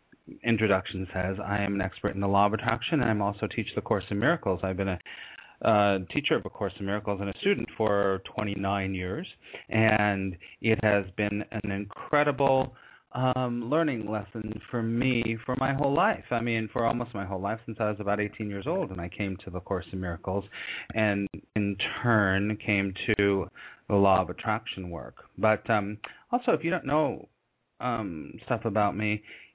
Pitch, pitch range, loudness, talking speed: 105 Hz, 100-115 Hz, -28 LUFS, 190 wpm